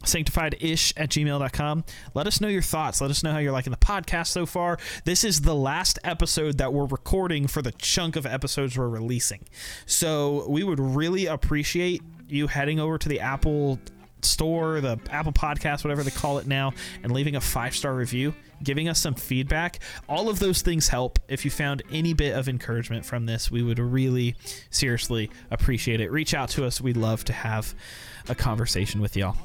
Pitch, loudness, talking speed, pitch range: 140 Hz, -26 LUFS, 190 wpm, 125-155 Hz